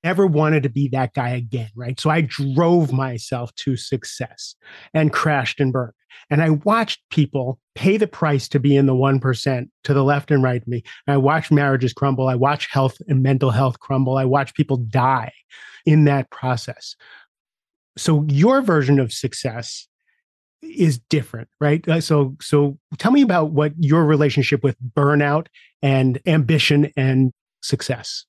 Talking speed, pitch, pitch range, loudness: 170 wpm, 140 Hz, 130-155 Hz, -19 LUFS